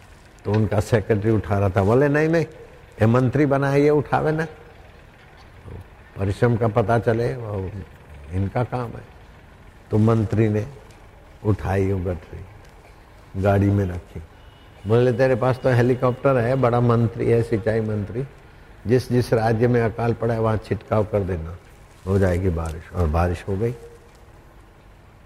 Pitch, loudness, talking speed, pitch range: 110 Hz, -21 LUFS, 145 wpm, 95-120 Hz